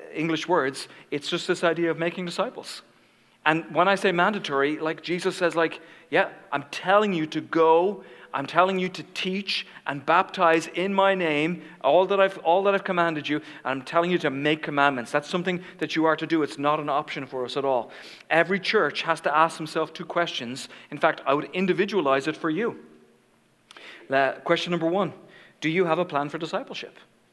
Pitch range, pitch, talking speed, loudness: 150-180 Hz, 165 Hz, 200 wpm, -25 LUFS